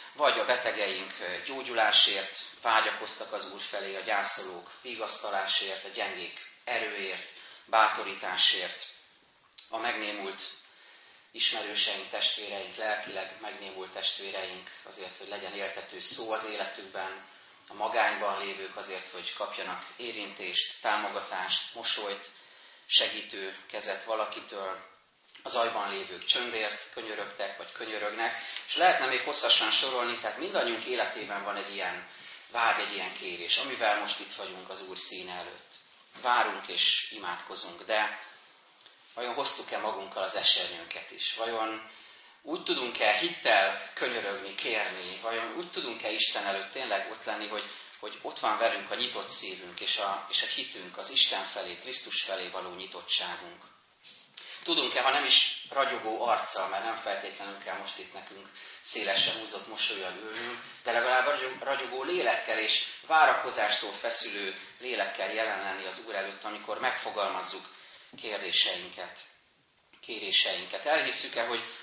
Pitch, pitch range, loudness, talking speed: 100 Hz, 95-110 Hz, -30 LUFS, 125 wpm